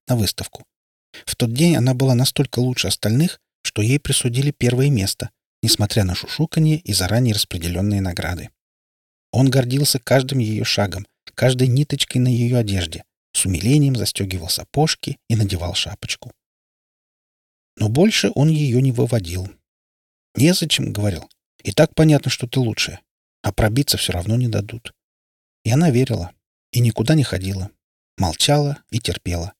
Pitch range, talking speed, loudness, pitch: 95-135 Hz, 140 wpm, -19 LUFS, 115 Hz